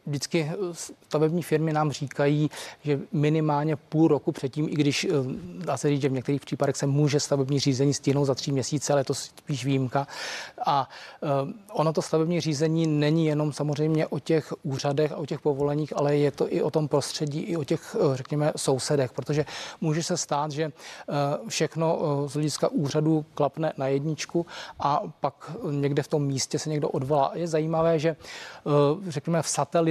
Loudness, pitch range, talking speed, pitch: -26 LUFS, 145-160 Hz, 175 wpm, 150 Hz